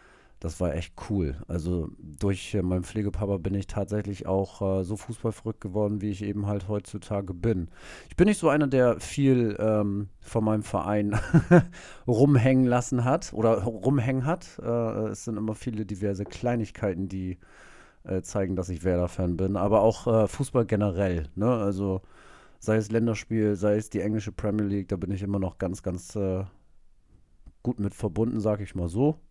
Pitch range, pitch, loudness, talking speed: 95-115 Hz, 105 Hz, -27 LUFS, 170 wpm